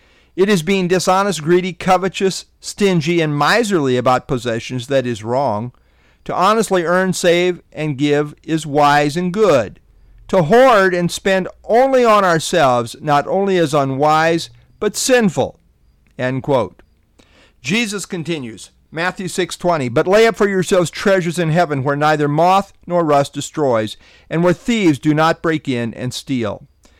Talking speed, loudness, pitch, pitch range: 145 wpm, -16 LUFS, 165 Hz, 135-185 Hz